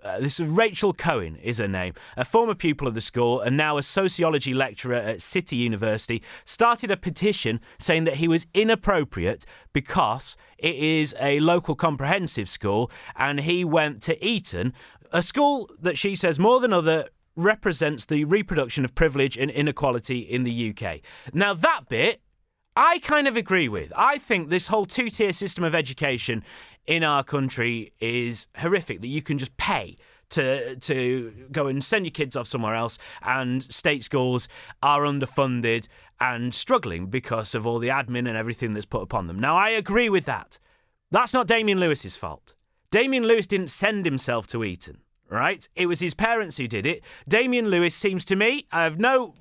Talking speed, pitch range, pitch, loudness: 180 wpm, 125-195 Hz, 150 Hz, -23 LUFS